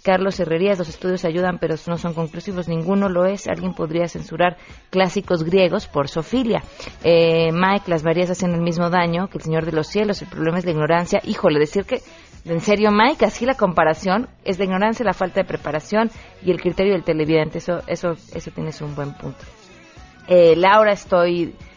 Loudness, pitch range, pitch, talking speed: -19 LUFS, 165-195 Hz, 180 Hz, 190 wpm